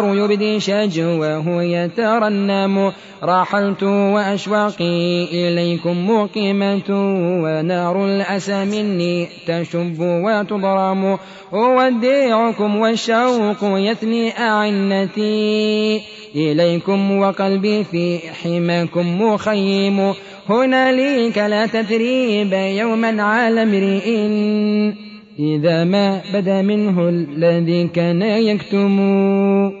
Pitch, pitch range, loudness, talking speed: 200 Hz, 175-210 Hz, -17 LUFS, 70 wpm